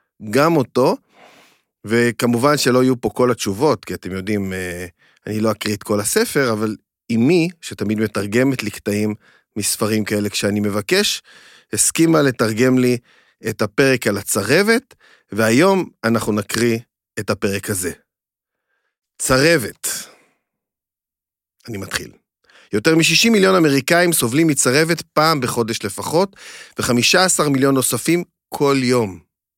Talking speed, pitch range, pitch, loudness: 115 wpm, 105-150 Hz, 120 Hz, -17 LUFS